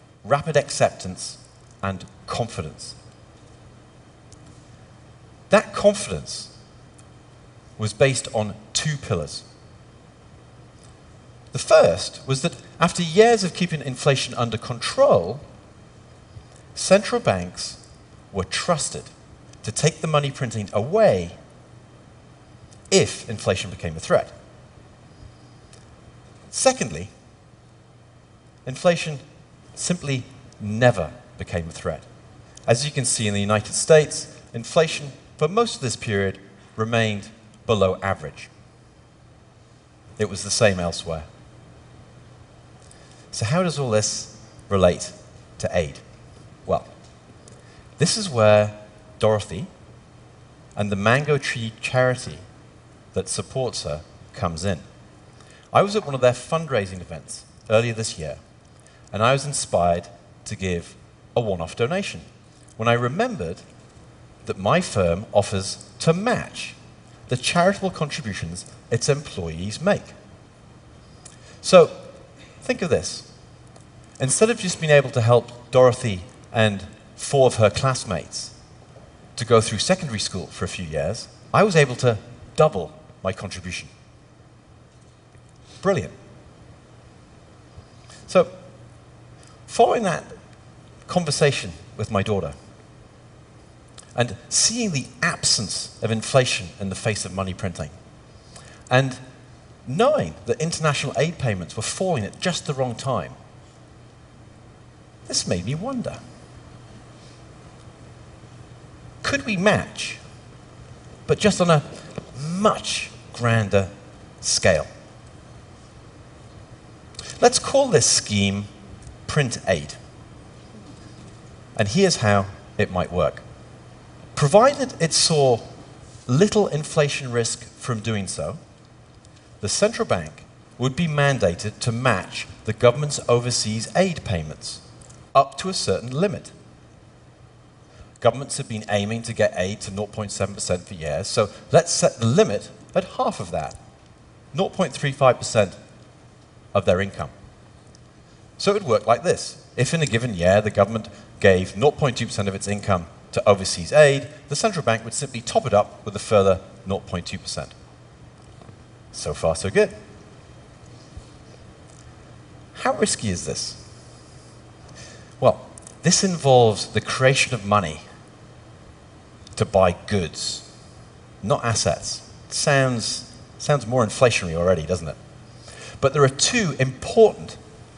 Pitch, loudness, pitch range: 120 Hz, -22 LUFS, 105-140 Hz